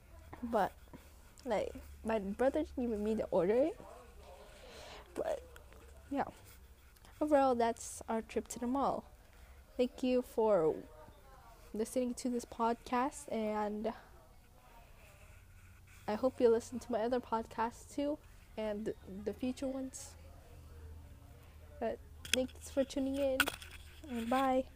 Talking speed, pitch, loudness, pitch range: 115 wpm, 235 Hz, -37 LUFS, 210-260 Hz